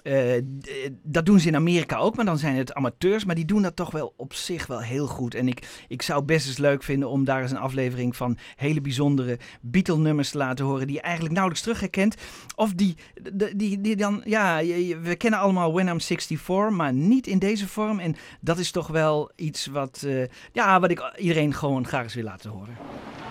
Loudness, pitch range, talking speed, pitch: -25 LUFS, 135-190 Hz, 220 wpm, 155 Hz